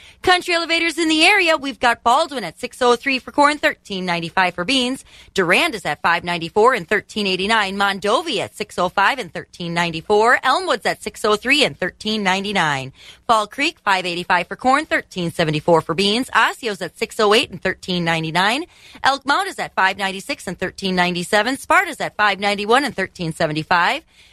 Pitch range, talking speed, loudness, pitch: 180-255 Hz, 140 wpm, -18 LUFS, 210 Hz